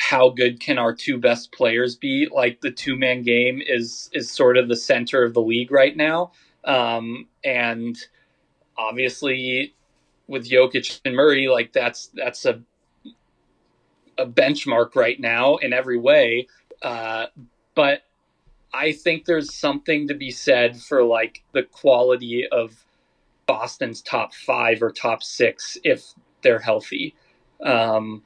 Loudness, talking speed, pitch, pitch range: -20 LUFS, 140 wpm, 125 Hz, 115-135 Hz